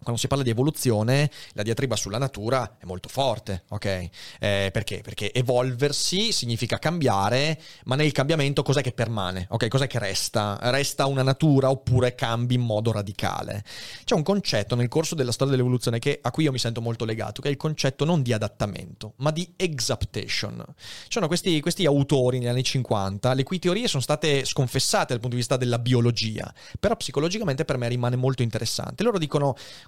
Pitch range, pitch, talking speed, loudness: 115-145 Hz, 125 Hz, 185 wpm, -25 LUFS